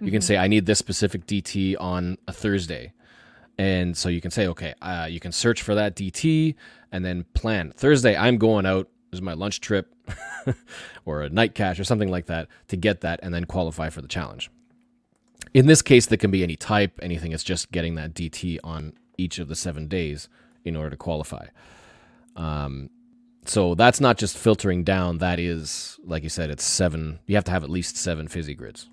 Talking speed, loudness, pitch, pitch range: 205 wpm, -23 LUFS, 90 Hz, 85-105 Hz